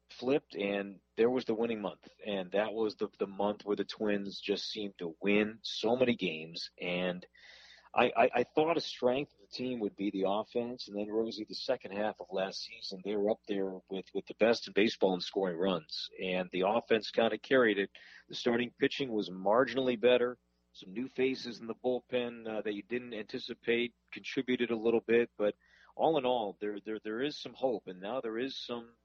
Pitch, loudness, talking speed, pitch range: 110 Hz, -34 LUFS, 210 wpm, 100-120 Hz